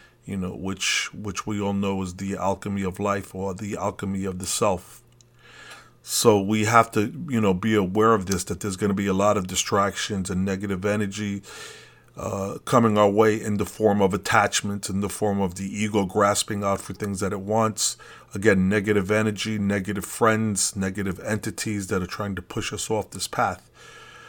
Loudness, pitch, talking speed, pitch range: -24 LUFS, 100 Hz, 195 wpm, 95-110 Hz